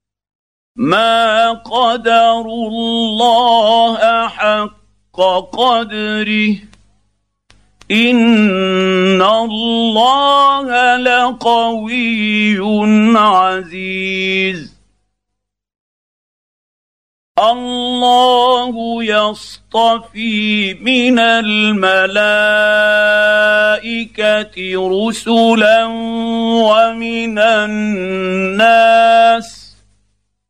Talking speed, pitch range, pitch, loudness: 30 wpm, 190-230 Hz, 215 Hz, -12 LUFS